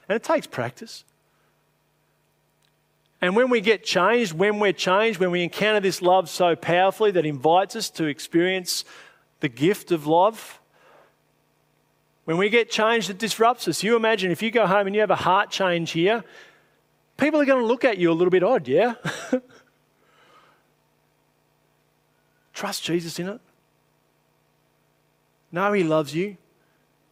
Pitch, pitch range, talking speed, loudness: 195 Hz, 175-225 Hz, 150 wpm, -22 LUFS